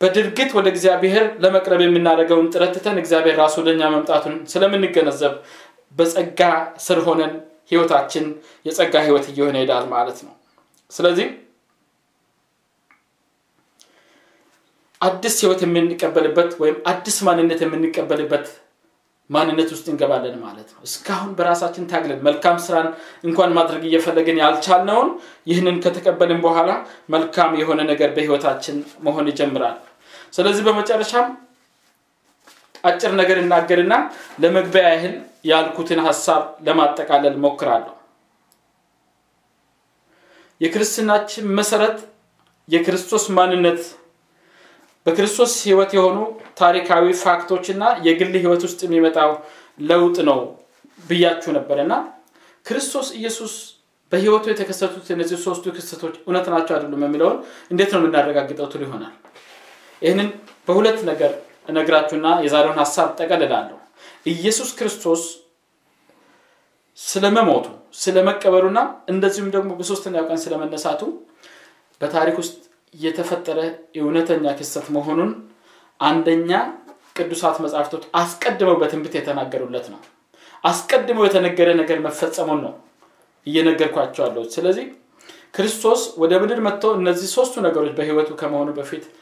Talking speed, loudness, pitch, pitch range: 95 wpm, -18 LUFS, 170 Hz, 160-190 Hz